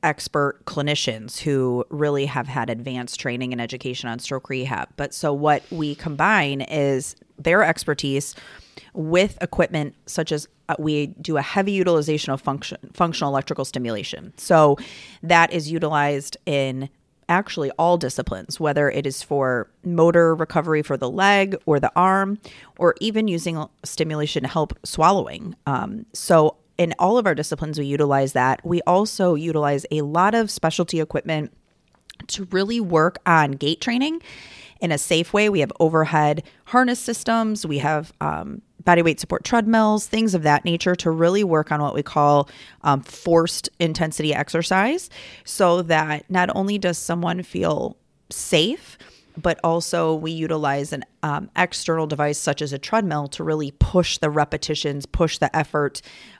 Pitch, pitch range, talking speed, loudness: 155 Hz, 145-175 Hz, 155 wpm, -21 LUFS